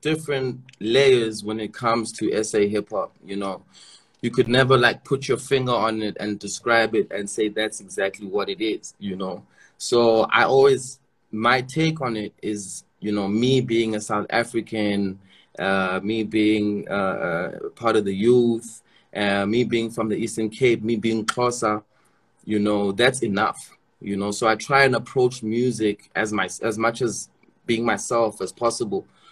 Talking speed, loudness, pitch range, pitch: 175 wpm, -22 LUFS, 105-125 Hz, 115 Hz